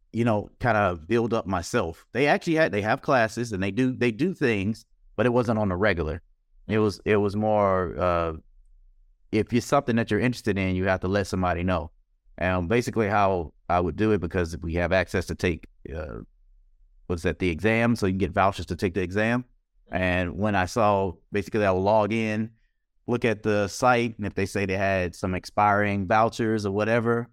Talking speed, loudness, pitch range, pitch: 210 wpm, -25 LUFS, 90-110 Hz, 100 Hz